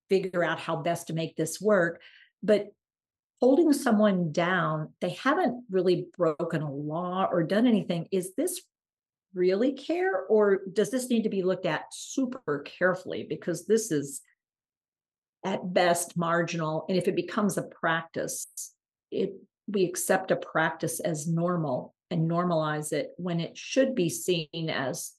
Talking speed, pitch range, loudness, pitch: 150 wpm, 165-205 Hz, -28 LUFS, 180 Hz